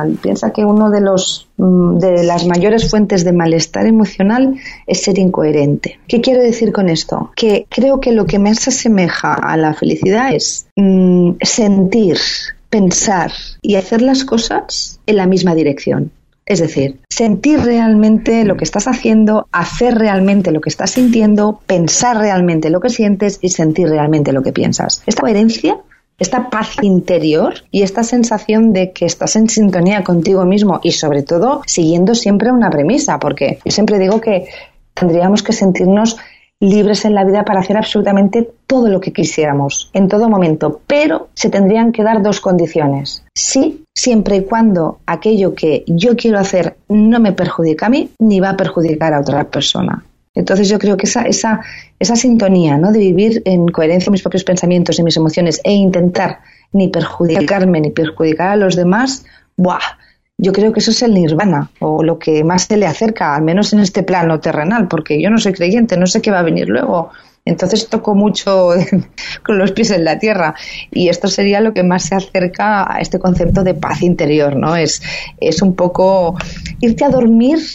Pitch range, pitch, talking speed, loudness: 175-220 Hz, 195 Hz, 180 wpm, -12 LUFS